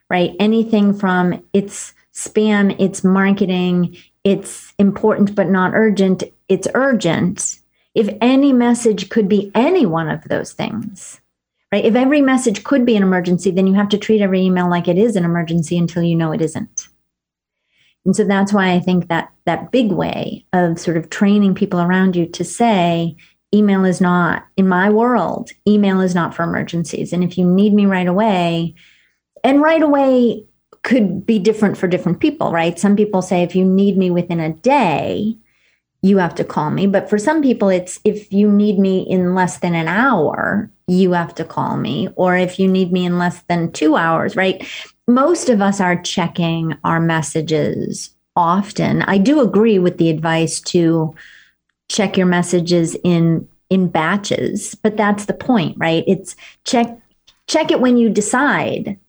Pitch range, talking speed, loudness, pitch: 175-215 Hz, 175 wpm, -16 LUFS, 190 Hz